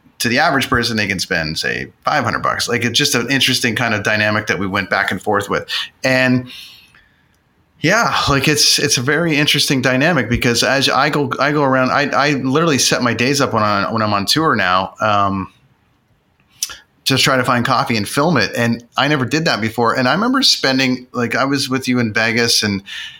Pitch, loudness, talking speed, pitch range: 125 Hz, -15 LUFS, 215 wpm, 115-135 Hz